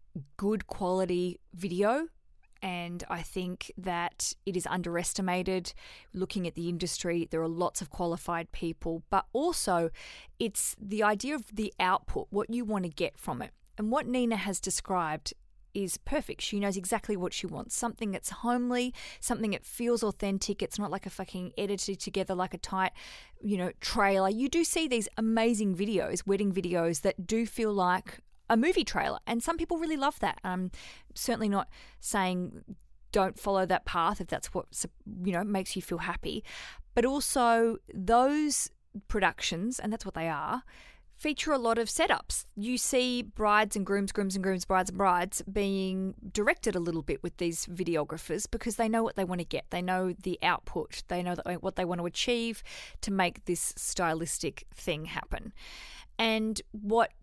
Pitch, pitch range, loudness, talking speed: 195 Hz, 180-225 Hz, -31 LUFS, 175 wpm